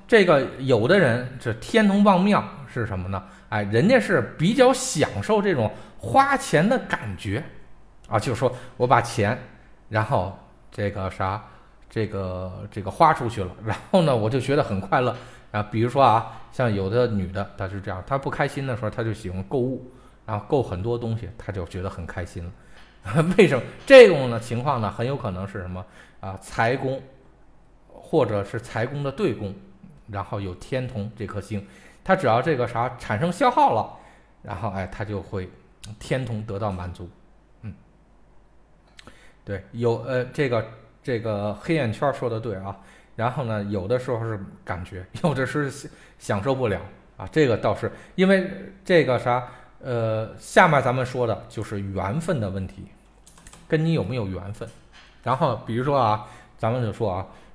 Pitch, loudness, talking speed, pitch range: 115 Hz, -23 LUFS, 245 characters per minute, 100-130 Hz